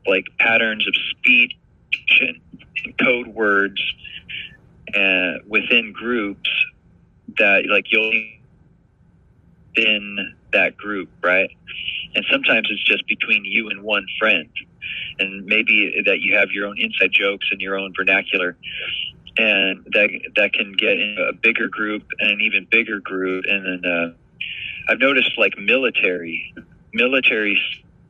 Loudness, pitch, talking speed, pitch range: -18 LUFS, 100 Hz, 130 wpm, 95-110 Hz